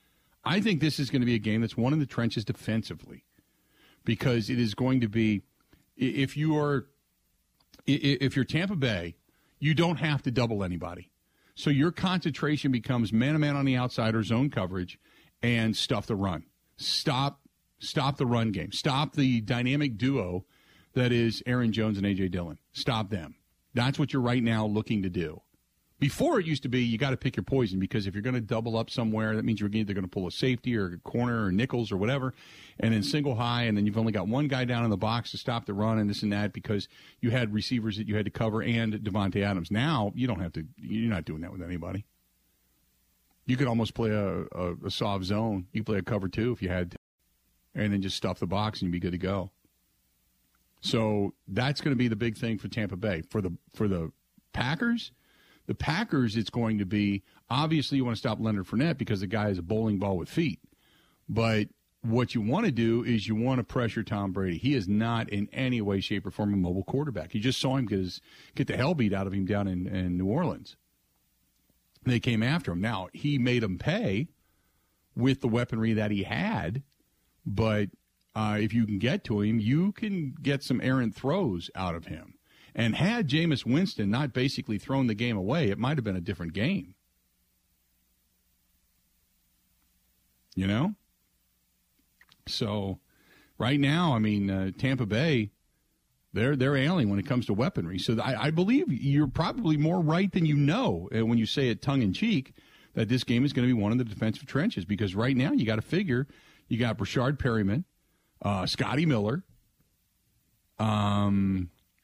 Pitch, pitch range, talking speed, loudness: 110 Hz, 100-130 Hz, 200 wpm, -29 LUFS